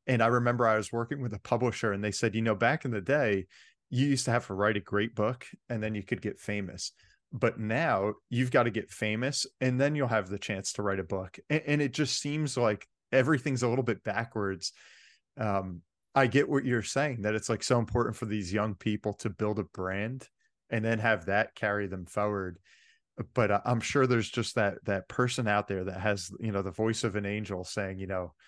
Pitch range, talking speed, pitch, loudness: 100-125 Hz, 230 wpm, 110 Hz, -30 LUFS